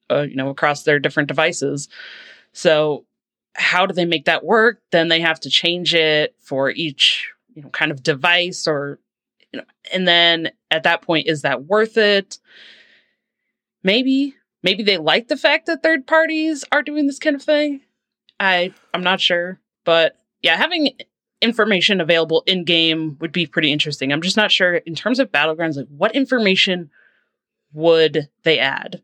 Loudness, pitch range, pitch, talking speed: -17 LUFS, 155-220 Hz, 175 Hz, 170 wpm